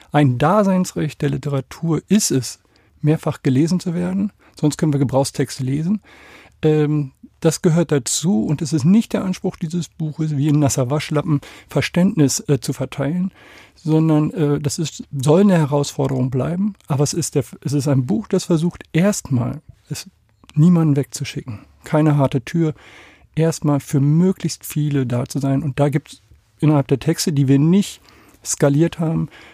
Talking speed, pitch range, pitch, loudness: 150 wpm, 140-170 Hz, 150 Hz, -19 LUFS